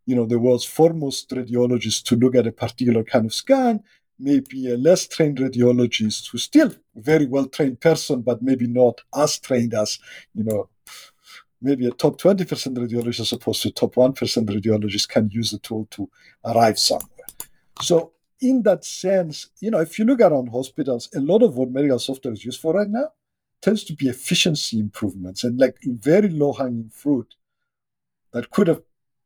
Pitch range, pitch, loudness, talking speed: 120-160 Hz, 130 Hz, -21 LUFS, 175 wpm